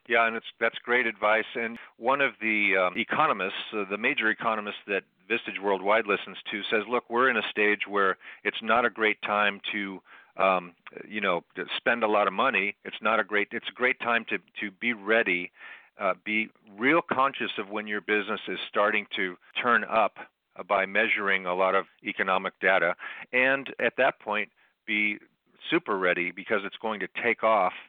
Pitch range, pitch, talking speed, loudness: 100-115 Hz, 105 Hz, 190 wpm, -26 LUFS